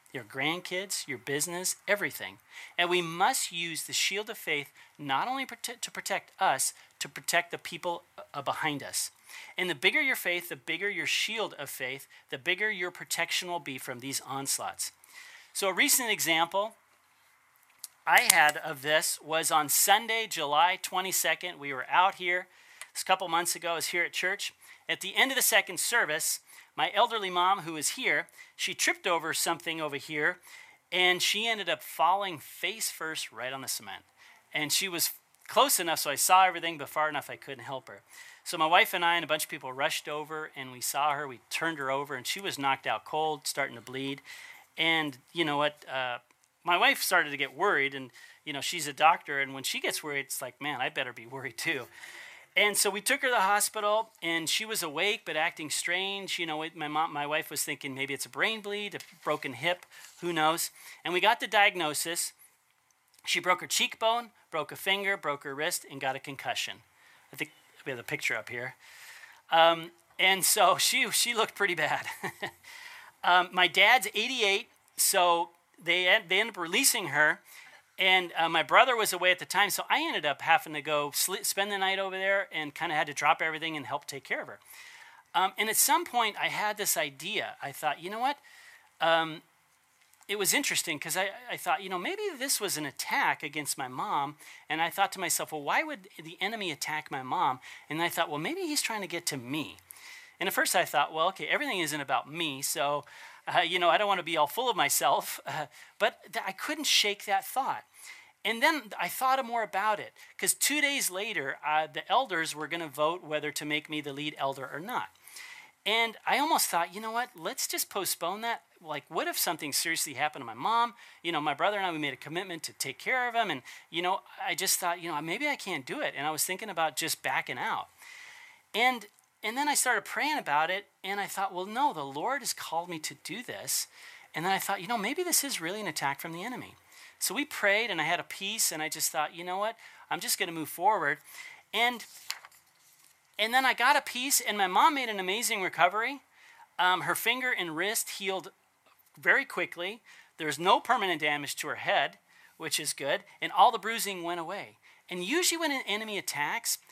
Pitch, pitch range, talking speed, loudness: 180 Hz, 155-220 Hz, 215 wpm, -29 LUFS